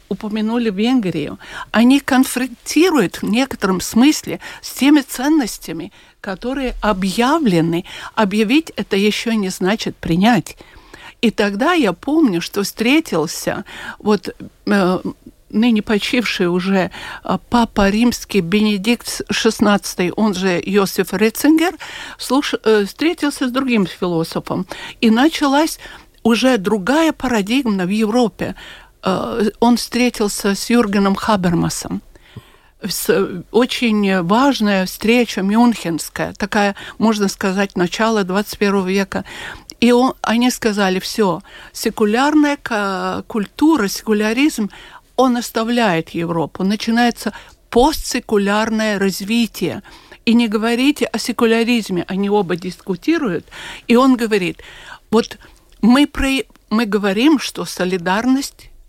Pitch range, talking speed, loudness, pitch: 200-245 Hz, 100 wpm, -17 LUFS, 220 Hz